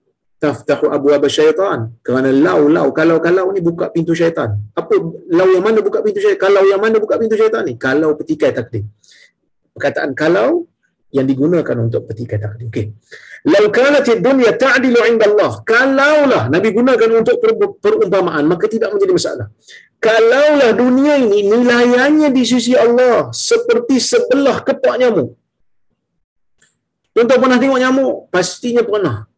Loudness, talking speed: -13 LUFS, 145 wpm